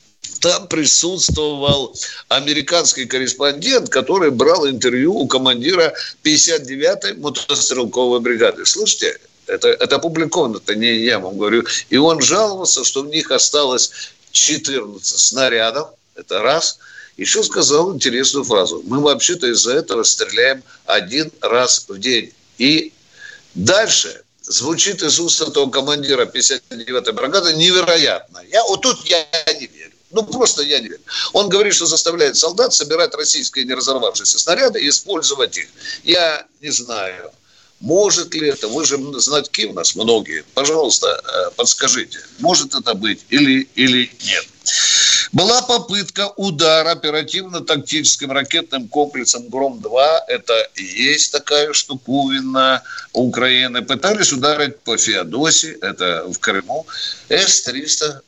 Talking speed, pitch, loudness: 125 wpm, 165 Hz, -15 LUFS